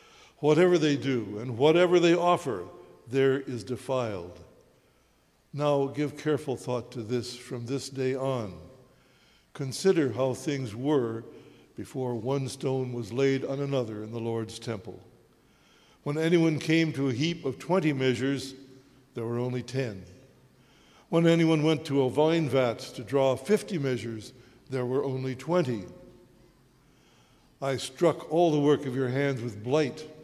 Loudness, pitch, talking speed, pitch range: -28 LUFS, 135 Hz, 145 wpm, 125-150 Hz